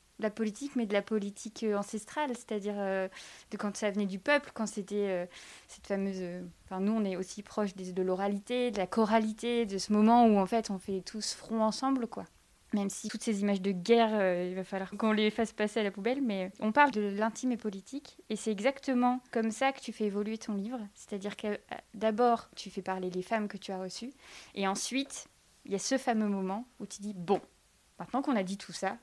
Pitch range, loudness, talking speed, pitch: 195-230 Hz, -32 LUFS, 230 wpm, 210 Hz